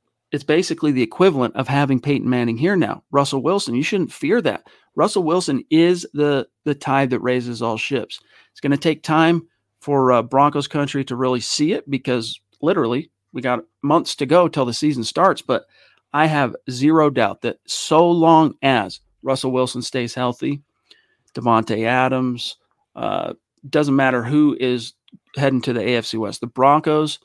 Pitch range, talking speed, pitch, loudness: 125-150 Hz, 170 wpm, 135 Hz, -19 LUFS